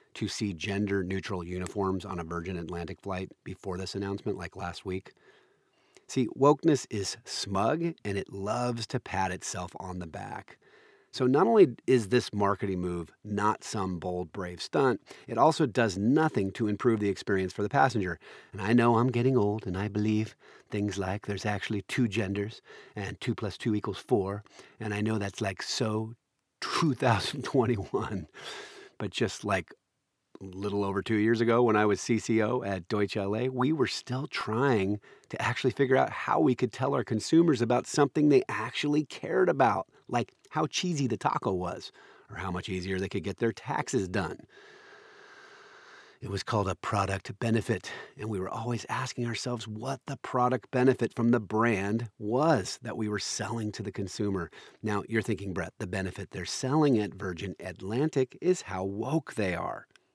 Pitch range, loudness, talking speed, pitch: 95-125 Hz, -30 LUFS, 175 wpm, 110 Hz